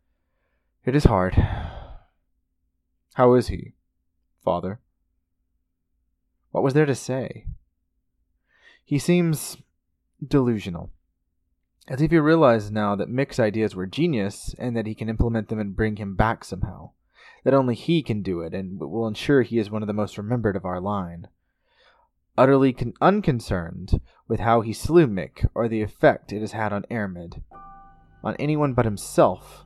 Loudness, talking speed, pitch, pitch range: -23 LUFS, 150 wpm, 105 Hz, 85-125 Hz